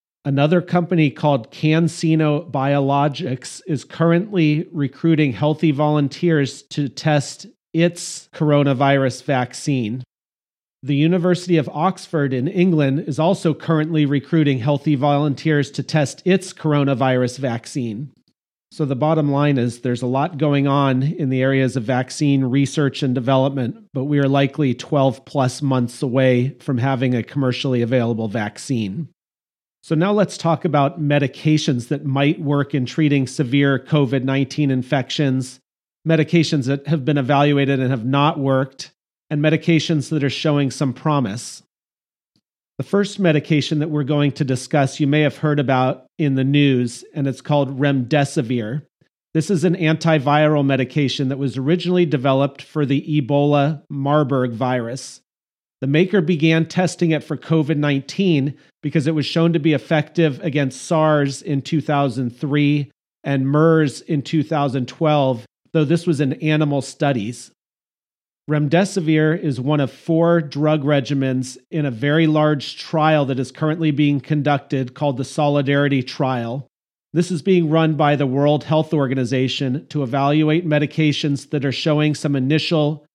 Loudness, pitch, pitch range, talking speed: -19 LUFS, 145 Hz, 135-155 Hz, 140 wpm